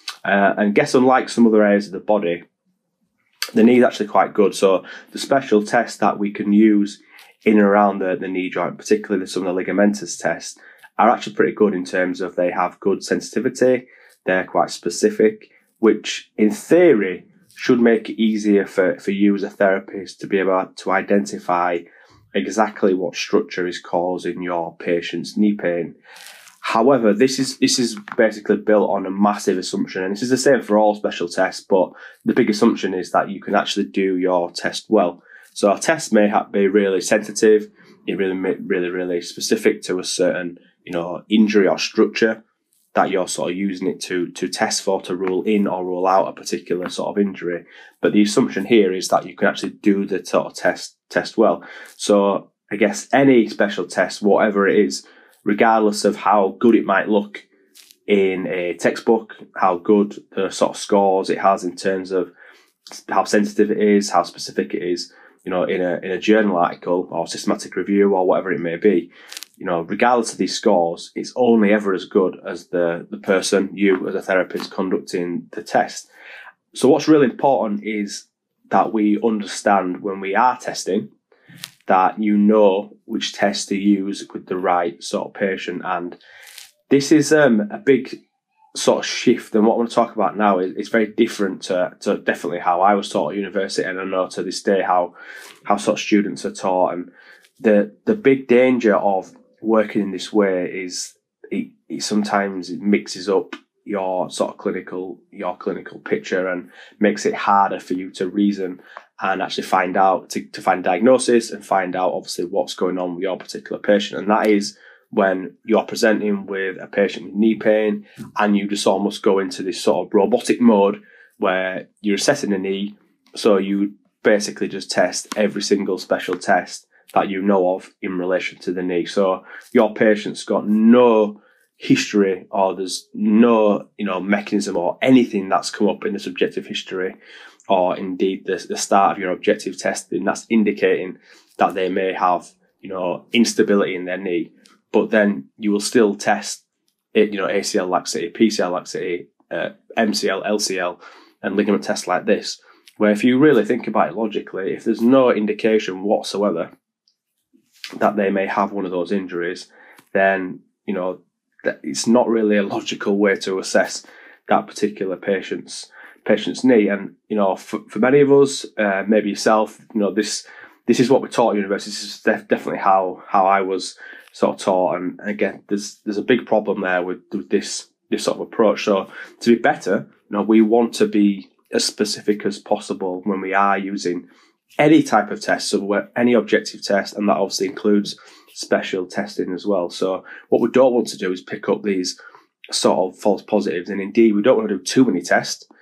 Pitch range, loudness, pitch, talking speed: 95-110 Hz, -19 LUFS, 100 Hz, 190 wpm